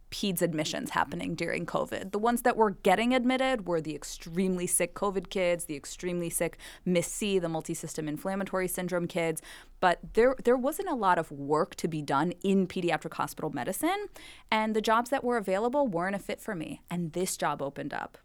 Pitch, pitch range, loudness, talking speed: 185 Hz, 170-225 Hz, -30 LUFS, 190 wpm